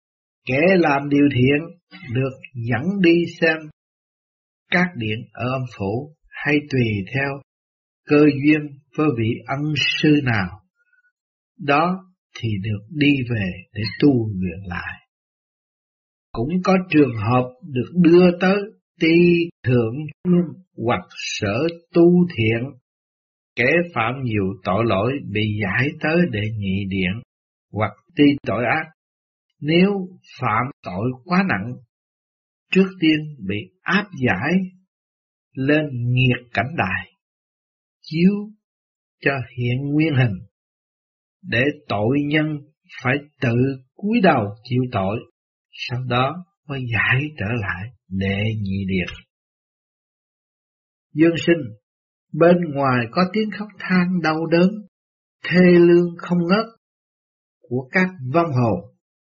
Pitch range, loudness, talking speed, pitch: 115-170 Hz, -20 LUFS, 115 wpm, 140 Hz